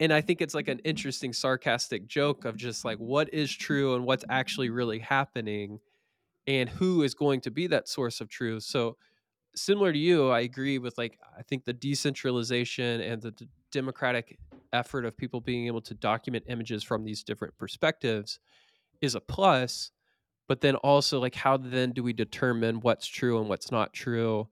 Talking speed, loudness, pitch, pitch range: 185 wpm, -29 LUFS, 125 Hz, 115-135 Hz